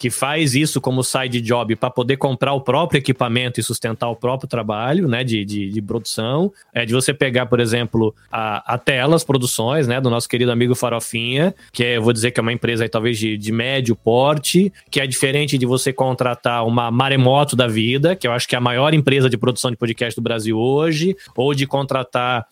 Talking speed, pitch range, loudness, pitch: 215 wpm, 120-135 Hz, -18 LUFS, 125 Hz